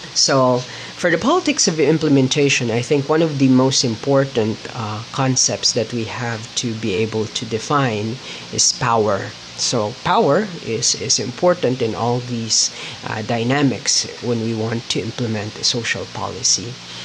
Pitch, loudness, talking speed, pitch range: 120 Hz, -18 LUFS, 150 wpm, 110-140 Hz